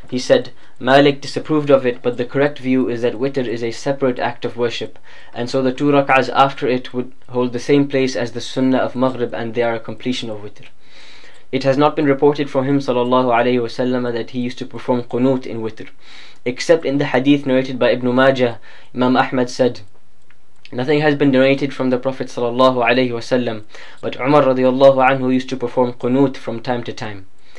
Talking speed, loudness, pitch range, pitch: 200 wpm, -17 LUFS, 120-135 Hz, 125 Hz